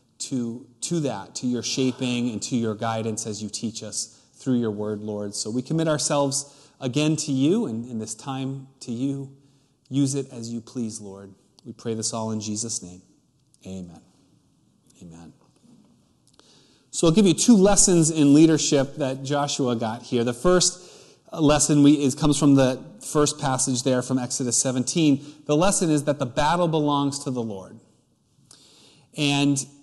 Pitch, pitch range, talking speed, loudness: 135 Hz, 115-145 Hz, 165 wpm, -23 LUFS